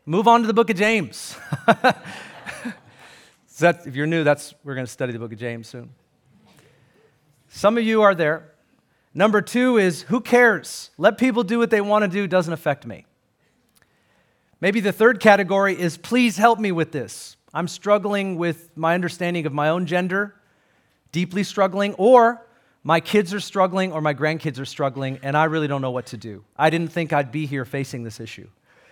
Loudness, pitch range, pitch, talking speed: -20 LUFS, 145-205 Hz, 170 Hz, 190 wpm